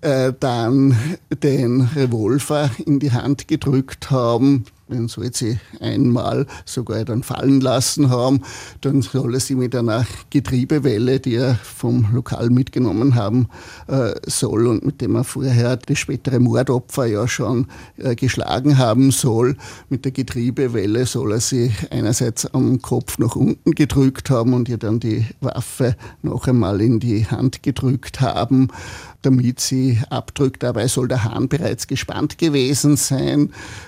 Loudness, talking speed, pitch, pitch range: -19 LUFS, 145 wpm, 125 Hz, 120-135 Hz